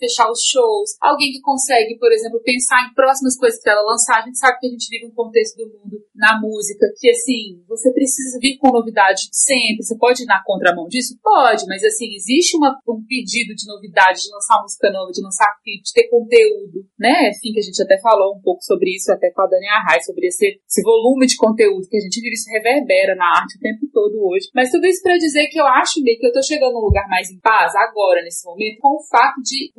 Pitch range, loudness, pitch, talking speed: 210-275 Hz, -15 LUFS, 235 Hz, 240 wpm